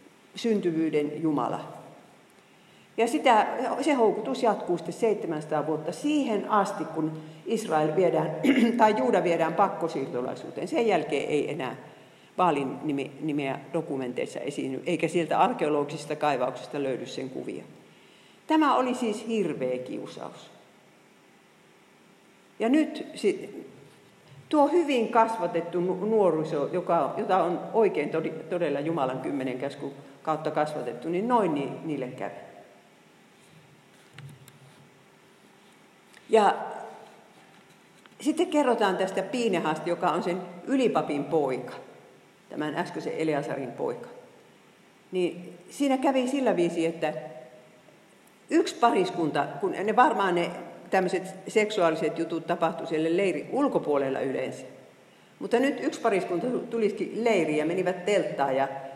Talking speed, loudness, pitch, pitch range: 105 wpm, -27 LUFS, 170 Hz, 150-215 Hz